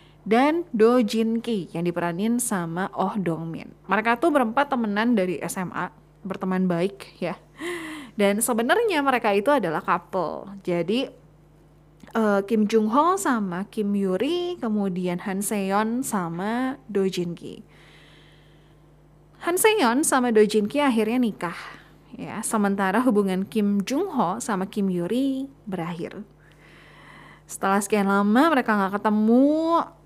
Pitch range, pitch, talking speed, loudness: 180-245 Hz, 205 Hz, 130 wpm, -23 LUFS